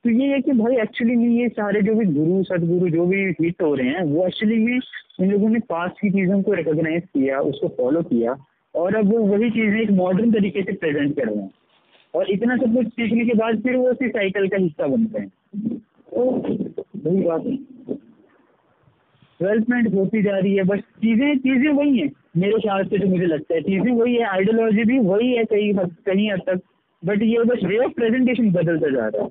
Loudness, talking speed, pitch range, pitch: -20 LUFS, 215 wpm, 185-235 Hz, 210 Hz